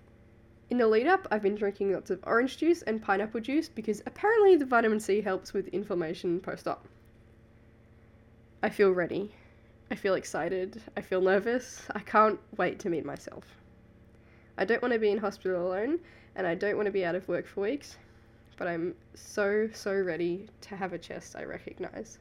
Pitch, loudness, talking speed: 190 Hz, -30 LUFS, 185 wpm